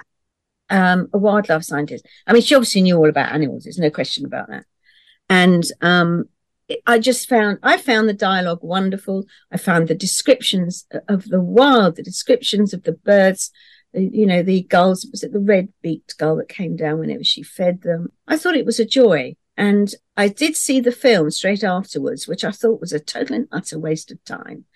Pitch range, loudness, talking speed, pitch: 170-230 Hz, -17 LUFS, 200 wpm, 190 Hz